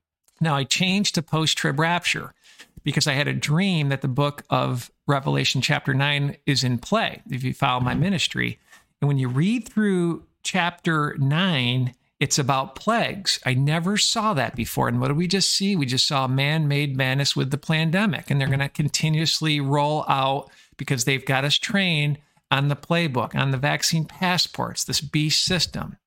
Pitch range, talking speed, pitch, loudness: 135-165 Hz, 175 wpm, 145 Hz, -22 LUFS